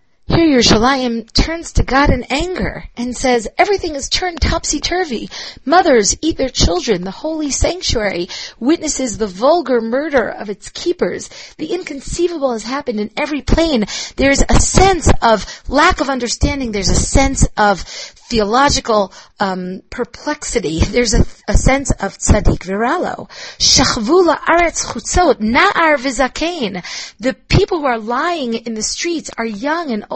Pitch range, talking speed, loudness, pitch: 225-320 Hz, 145 wpm, -15 LUFS, 265 Hz